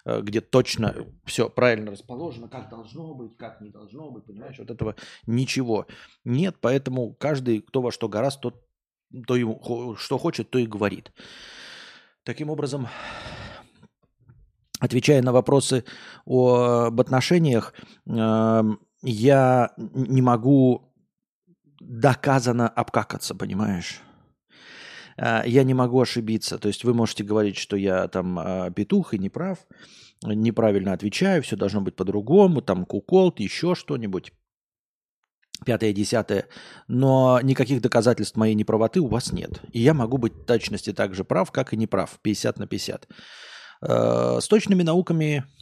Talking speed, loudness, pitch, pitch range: 130 wpm, -23 LUFS, 120 Hz, 110-135 Hz